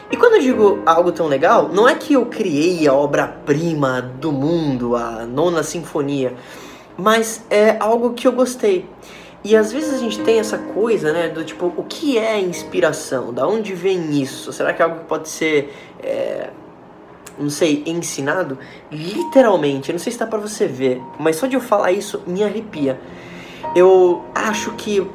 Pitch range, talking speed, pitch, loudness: 145-220 Hz, 180 wpm, 175 Hz, -18 LUFS